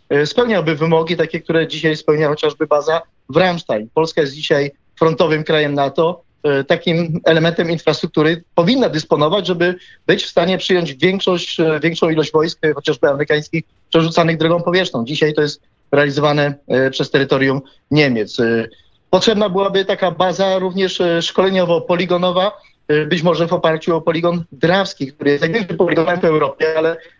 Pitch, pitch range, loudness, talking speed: 165 Hz, 150-180 Hz, -16 LUFS, 140 wpm